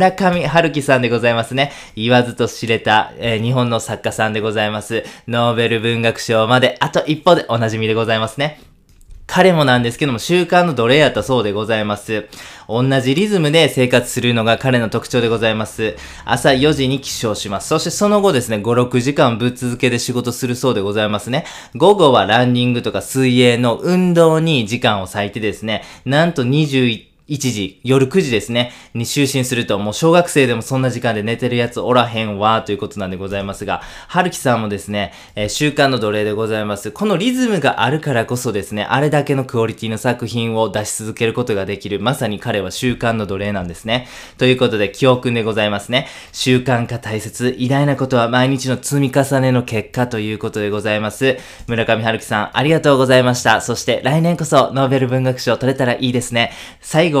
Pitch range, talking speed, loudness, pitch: 110-135 Hz, 410 characters per minute, -16 LUFS, 120 Hz